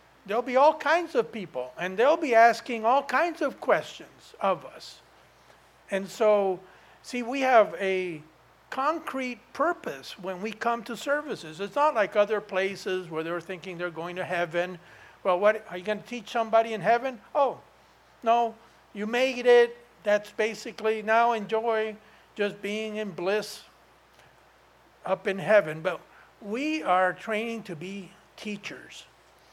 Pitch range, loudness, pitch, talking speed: 190-240 Hz, -27 LUFS, 215 Hz, 150 wpm